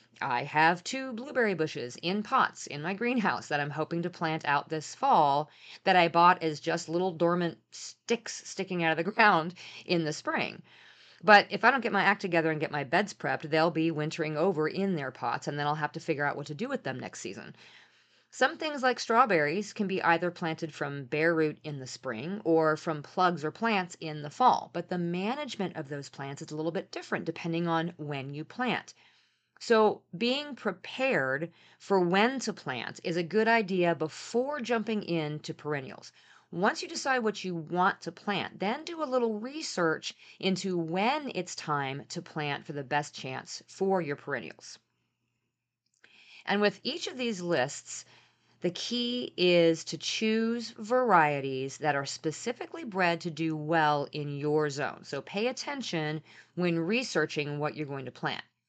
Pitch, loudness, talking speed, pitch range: 170 Hz, -30 LUFS, 185 wpm, 150-205 Hz